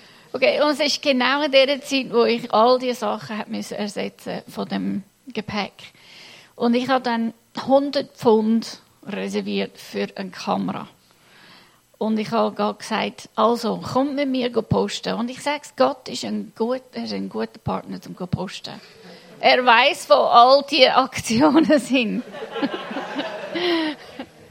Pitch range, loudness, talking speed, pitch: 210-270 Hz, -21 LUFS, 145 wpm, 235 Hz